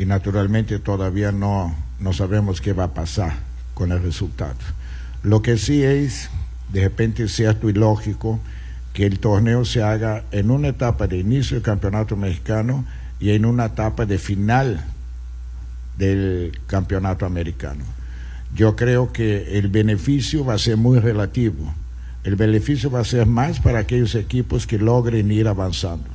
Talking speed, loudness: 155 wpm, -20 LUFS